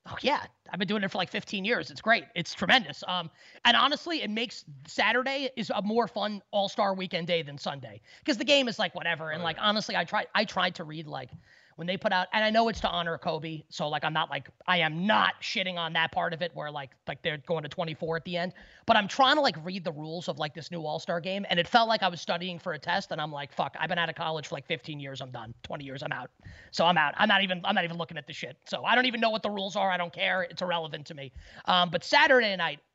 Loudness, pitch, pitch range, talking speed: -28 LUFS, 175 Hz, 160-210 Hz, 285 wpm